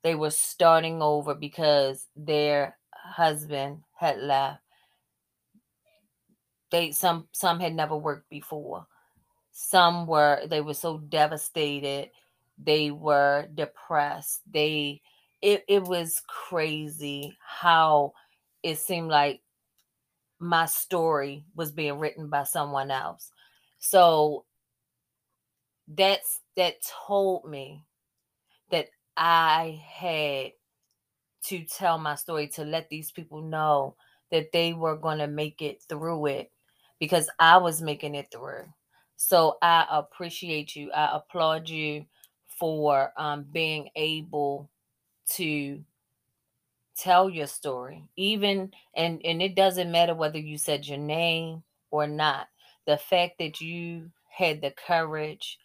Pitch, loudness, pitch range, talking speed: 155 Hz, -26 LUFS, 145-165 Hz, 115 wpm